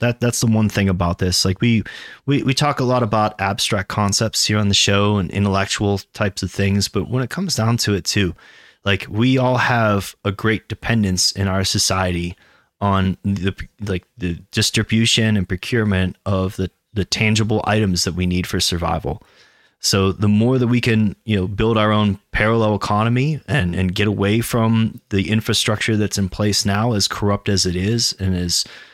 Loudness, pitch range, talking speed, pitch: -18 LUFS, 95-115 Hz, 190 wpm, 105 Hz